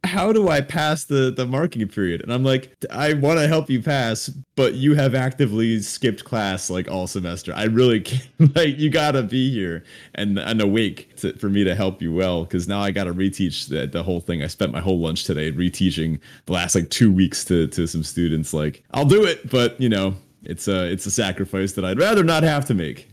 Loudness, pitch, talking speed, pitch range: -21 LUFS, 105 Hz, 230 wpm, 90-135 Hz